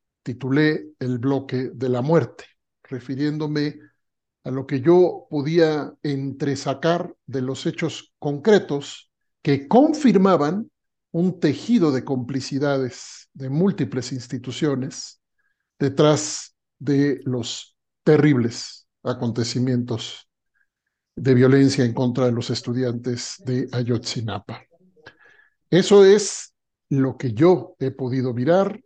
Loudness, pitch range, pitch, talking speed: -21 LUFS, 130-160 Hz, 140 Hz, 100 wpm